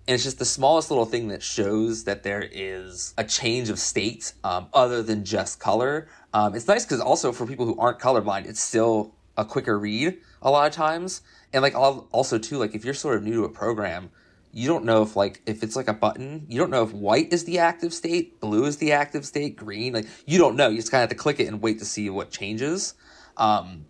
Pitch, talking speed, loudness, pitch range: 115 Hz, 245 wpm, -24 LUFS, 105-145 Hz